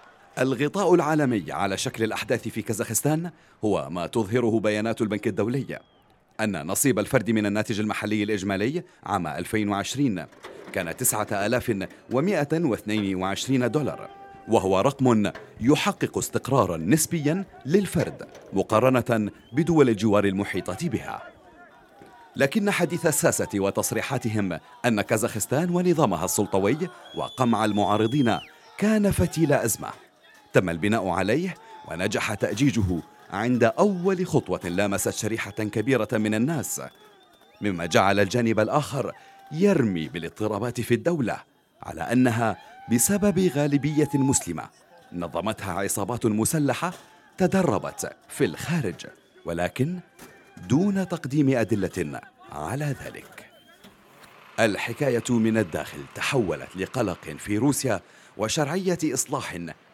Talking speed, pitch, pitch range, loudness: 95 wpm, 115 Hz, 105-145 Hz, -25 LUFS